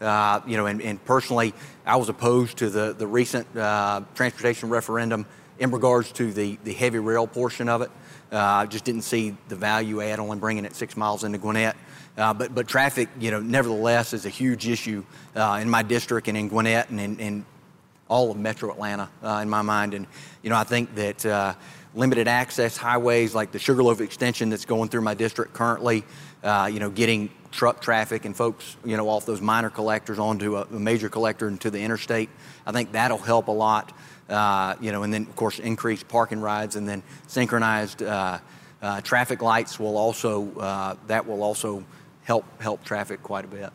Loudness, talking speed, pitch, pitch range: -25 LUFS, 200 wpm, 110 Hz, 105-120 Hz